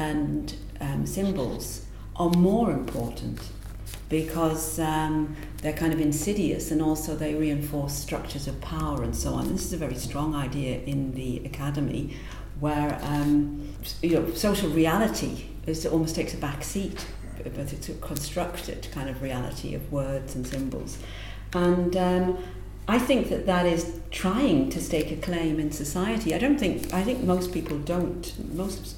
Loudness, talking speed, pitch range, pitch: -28 LUFS, 160 wpm, 135-170 Hz, 150 Hz